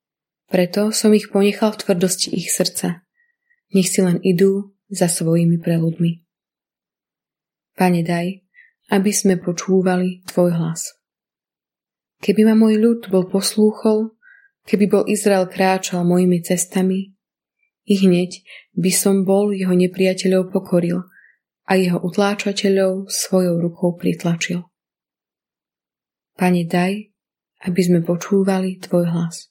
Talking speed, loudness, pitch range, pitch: 110 wpm, -18 LUFS, 180-205 Hz, 190 Hz